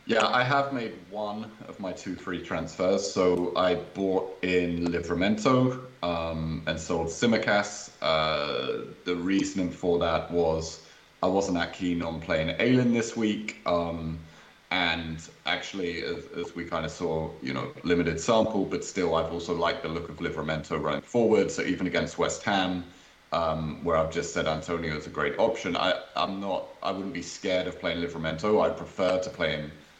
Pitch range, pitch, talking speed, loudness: 80-95 Hz, 90 Hz, 175 wpm, -28 LUFS